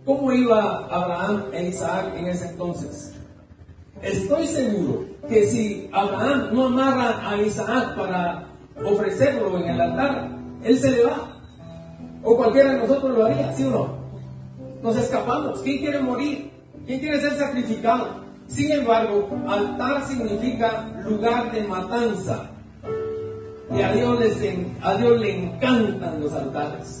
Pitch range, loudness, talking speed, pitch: 185-260 Hz, -22 LUFS, 130 wpm, 225 Hz